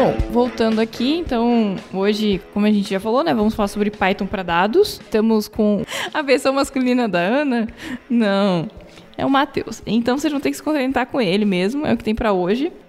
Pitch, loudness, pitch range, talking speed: 225 Hz, -19 LUFS, 205-260 Hz, 205 wpm